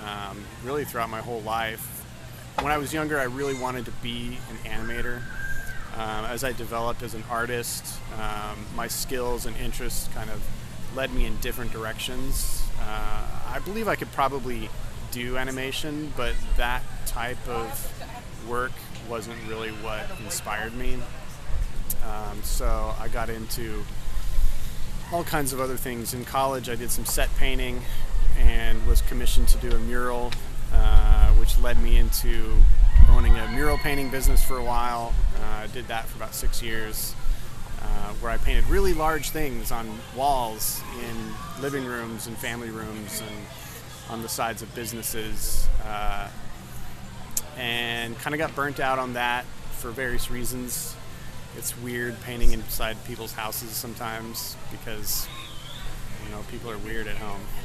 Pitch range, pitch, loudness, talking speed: 110-125 Hz, 115 Hz, -29 LUFS, 155 wpm